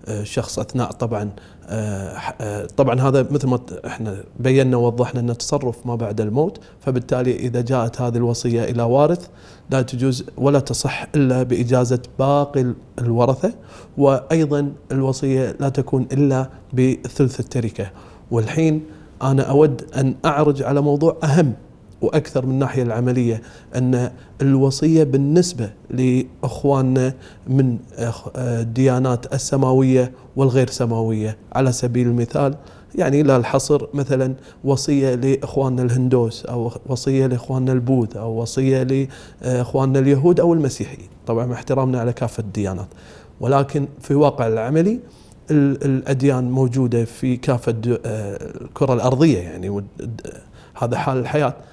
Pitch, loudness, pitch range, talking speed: 130 Hz, -19 LUFS, 120-140 Hz, 115 wpm